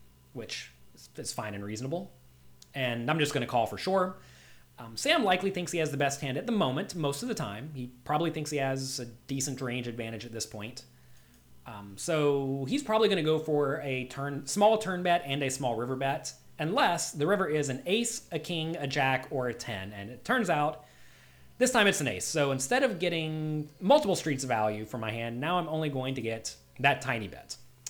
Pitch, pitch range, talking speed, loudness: 135 Hz, 120-165 Hz, 215 wpm, -30 LUFS